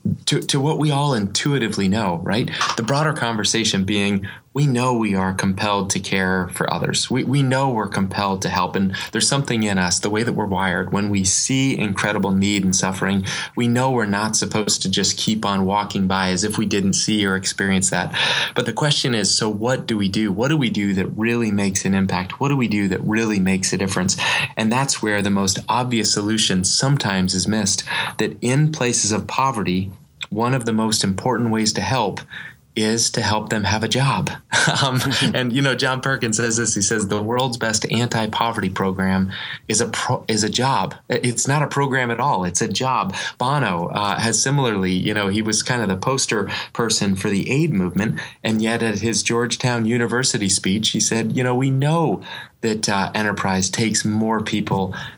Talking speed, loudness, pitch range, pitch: 205 wpm, -19 LUFS, 100-125 Hz, 110 Hz